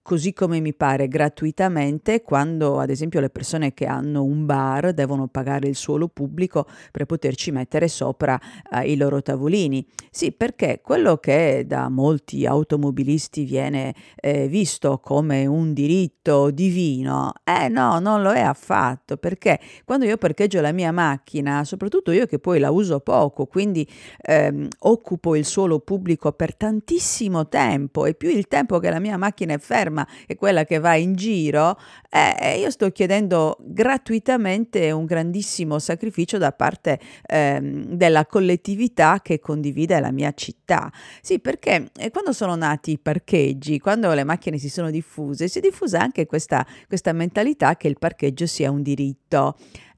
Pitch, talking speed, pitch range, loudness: 155 Hz, 155 wpm, 140-185 Hz, -21 LUFS